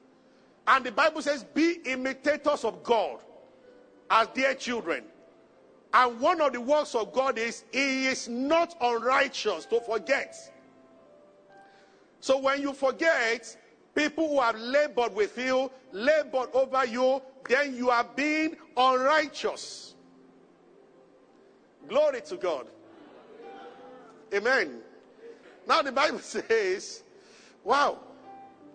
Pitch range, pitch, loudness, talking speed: 250-305 Hz, 270 Hz, -27 LUFS, 110 wpm